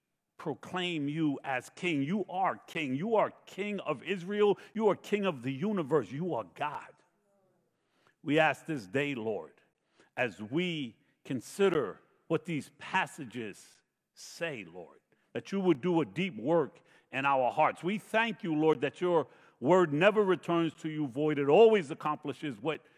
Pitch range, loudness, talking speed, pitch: 145-190 Hz, -31 LUFS, 155 wpm, 165 Hz